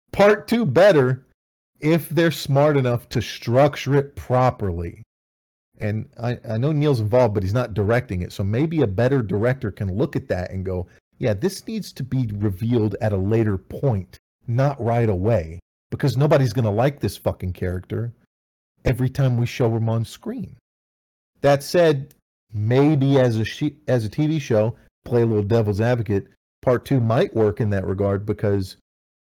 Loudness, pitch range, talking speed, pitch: -21 LUFS, 100-135 Hz, 170 wpm, 115 Hz